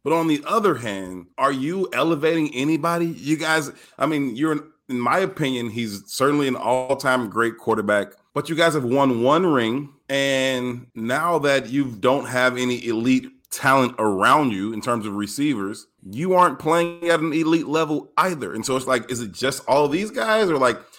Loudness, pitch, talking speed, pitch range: -21 LUFS, 135 Hz, 190 wpm, 120-160 Hz